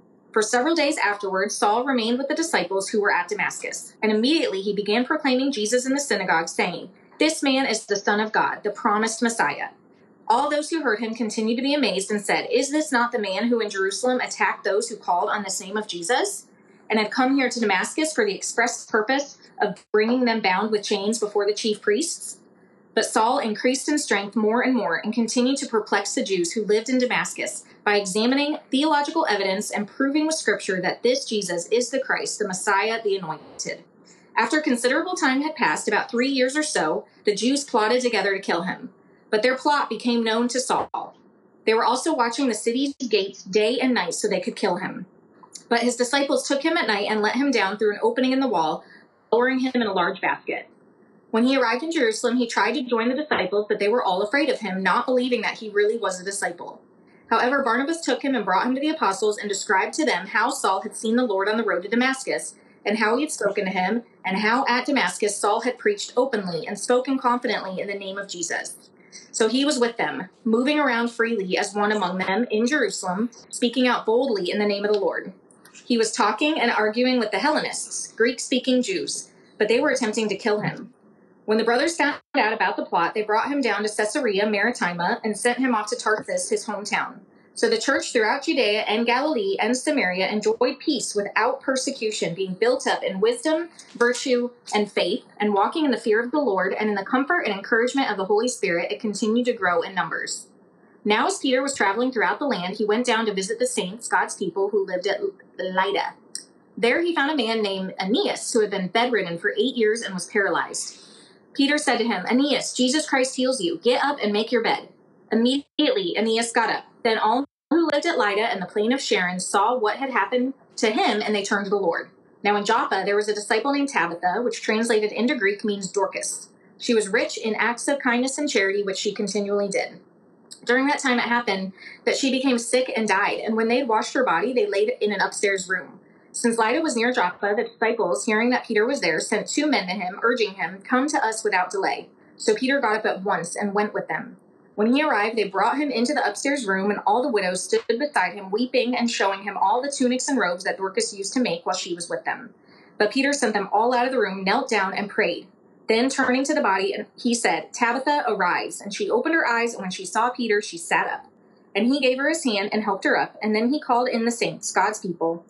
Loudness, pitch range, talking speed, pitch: -23 LUFS, 205-260 Hz, 225 wpm, 230 Hz